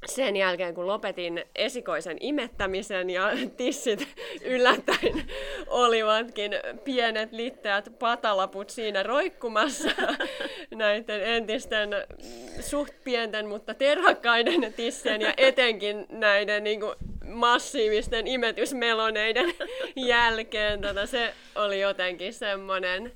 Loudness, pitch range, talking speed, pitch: -26 LUFS, 205-265 Hz, 90 wpm, 230 Hz